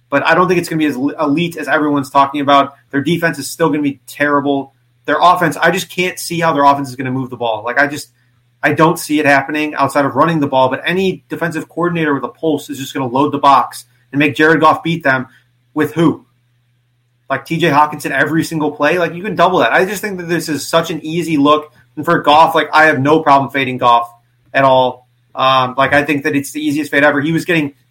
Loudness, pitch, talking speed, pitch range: -14 LUFS, 145 Hz, 250 wpm, 135-160 Hz